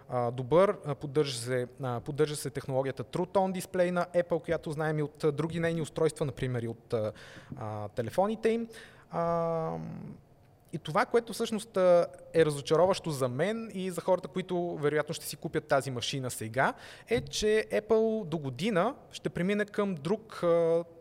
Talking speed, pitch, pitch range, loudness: 150 wpm, 165 Hz, 140-185 Hz, -31 LUFS